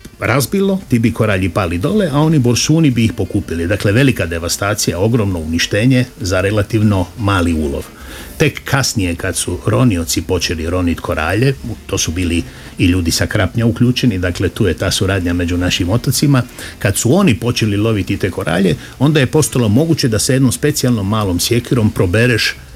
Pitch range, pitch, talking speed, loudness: 90-125 Hz, 105 Hz, 165 wpm, -14 LUFS